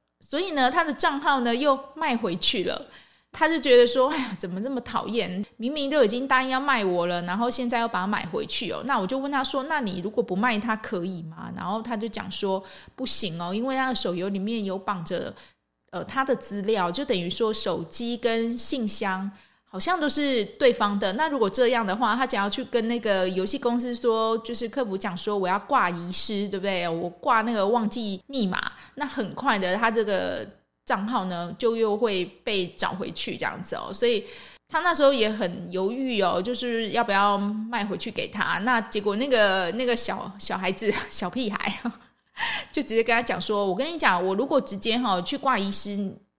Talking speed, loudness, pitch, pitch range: 290 characters per minute, -25 LUFS, 225 Hz, 195-250 Hz